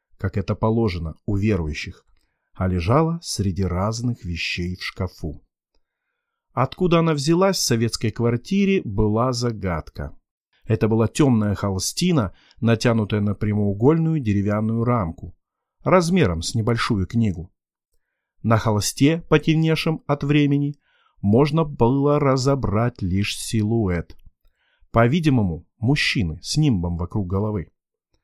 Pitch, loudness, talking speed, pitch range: 115 Hz, -21 LUFS, 105 wpm, 100-145 Hz